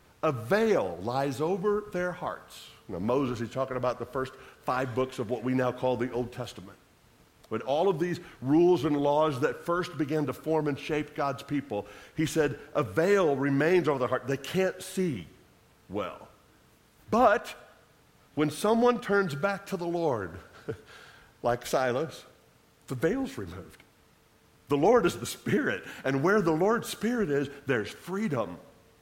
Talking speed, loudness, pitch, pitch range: 160 wpm, -29 LUFS, 145 Hz, 130-175 Hz